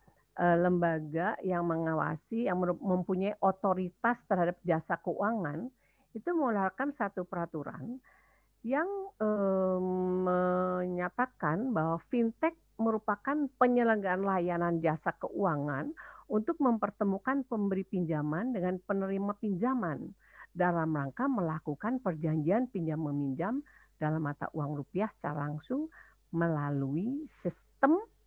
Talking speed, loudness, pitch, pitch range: 95 wpm, -32 LUFS, 185 Hz, 165-230 Hz